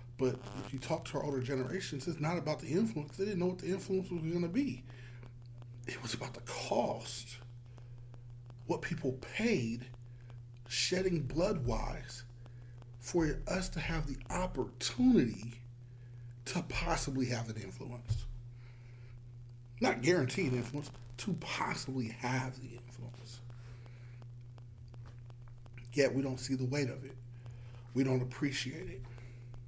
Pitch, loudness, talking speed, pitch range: 125 Hz, -36 LUFS, 135 wpm, 120-140 Hz